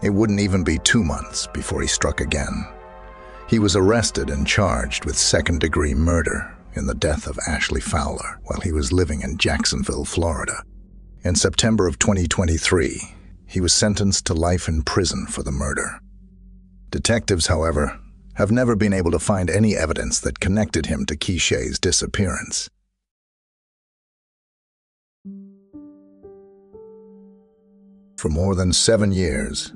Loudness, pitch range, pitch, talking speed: -20 LUFS, 85-110 Hz, 95 Hz, 135 wpm